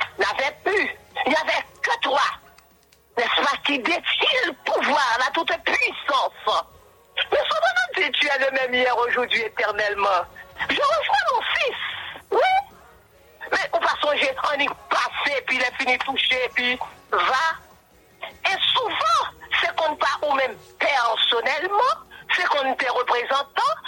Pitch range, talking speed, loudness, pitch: 250-345 Hz, 145 wpm, -21 LUFS, 280 Hz